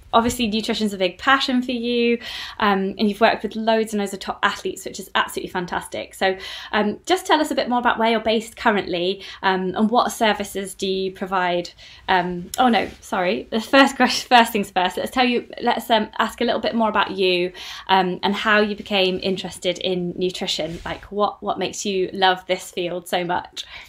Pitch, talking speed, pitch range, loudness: 205 Hz, 205 wpm, 185-230 Hz, -21 LUFS